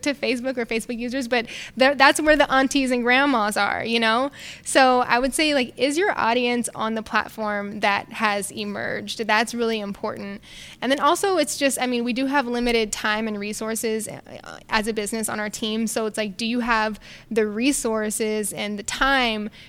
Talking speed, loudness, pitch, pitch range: 190 wpm, -22 LUFS, 230 Hz, 215-265 Hz